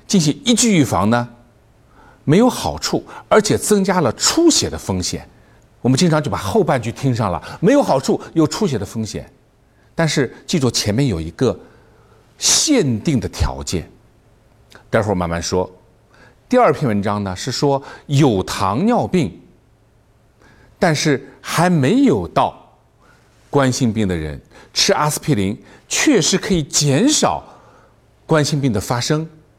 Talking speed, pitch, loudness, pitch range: 210 characters per minute, 130 Hz, -17 LUFS, 110-155 Hz